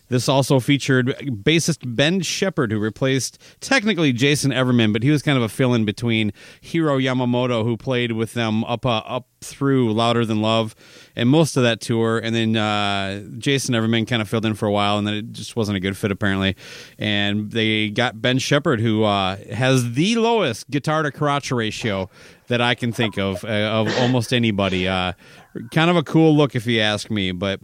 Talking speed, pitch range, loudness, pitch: 200 wpm, 110-135 Hz, -20 LUFS, 120 Hz